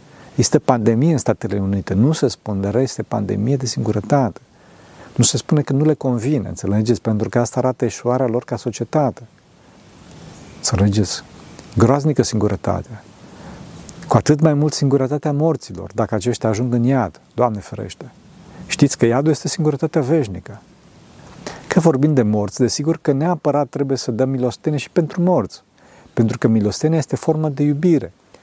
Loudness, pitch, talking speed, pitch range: -18 LUFS, 125 Hz, 150 wpm, 110-150 Hz